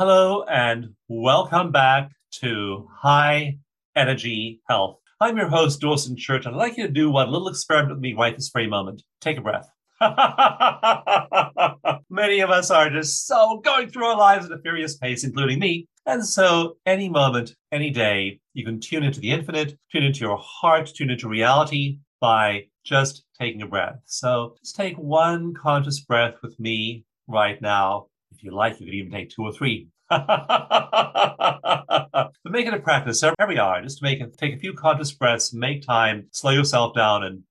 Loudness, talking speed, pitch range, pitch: -21 LUFS, 180 wpm, 115-160 Hz, 140 Hz